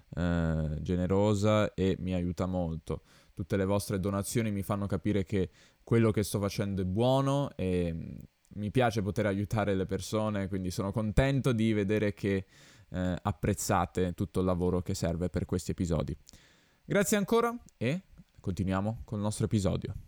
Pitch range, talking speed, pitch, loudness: 90-110 Hz, 150 wpm, 100 Hz, -31 LUFS